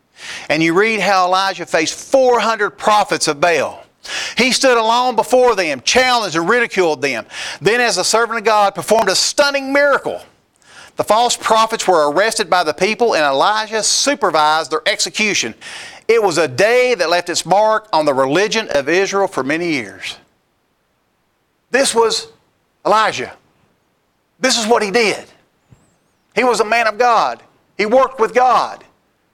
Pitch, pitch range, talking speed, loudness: 220 Hz, 185-245 Hz, 155 wpm, -14 LUFS